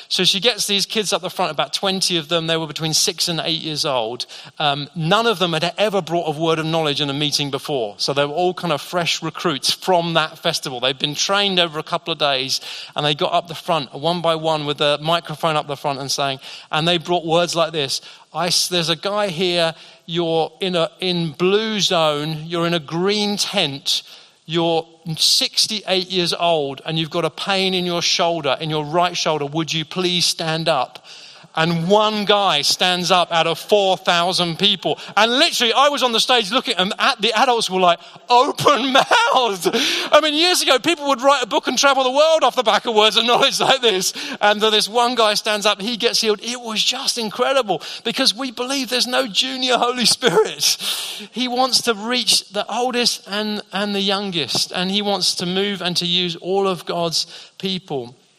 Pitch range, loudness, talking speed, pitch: 165-215 Hz, -18 LUFS, 210 wpm, 180 Hz